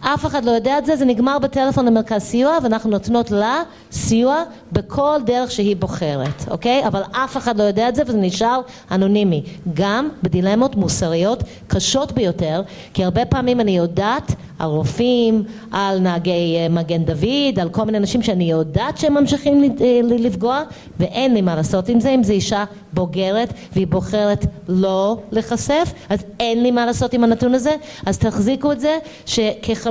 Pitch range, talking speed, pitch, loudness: 190-255 Hz, 165 wpm, 220 Hz, -18 LUFS